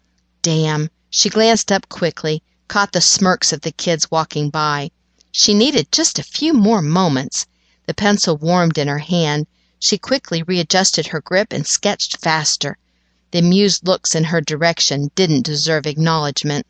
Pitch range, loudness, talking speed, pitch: 150-190 Hz, -16 LUFS, 155 wpm, 165 Hz